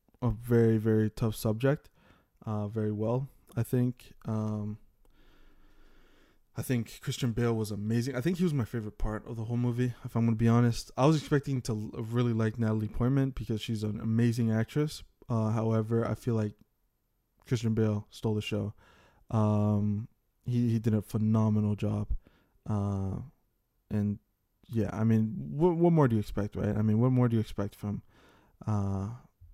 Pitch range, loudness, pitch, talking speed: 105-120 Hz, -30 LUFS, 110 Hz, 175 wpm